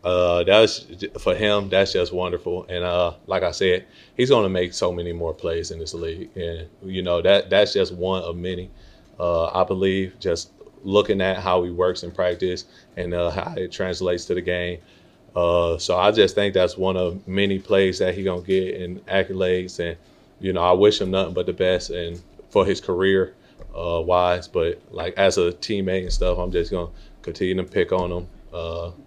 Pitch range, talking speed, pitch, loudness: 85-95 Hz, 210 wpm, 90 Hz, -22 LUFS